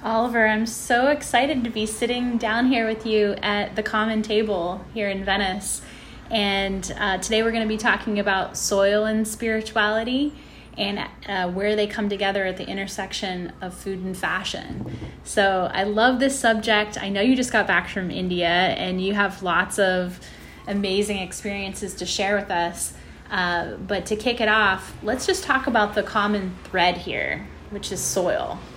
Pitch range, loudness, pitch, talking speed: 190-220 Hz, -23 LUFS, 205 Hz, 175 wpm